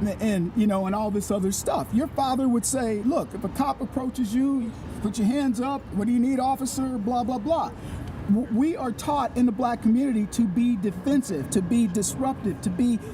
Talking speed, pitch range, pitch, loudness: 210 wpm, 210-265 Hz, 240 Hz, -25 LUFS